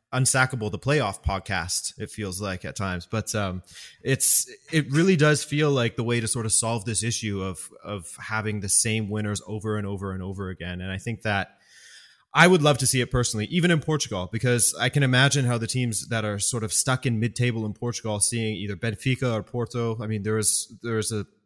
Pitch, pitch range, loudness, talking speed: 110 Hz, 105-125 Hz, -24 LUFS, 225 wpm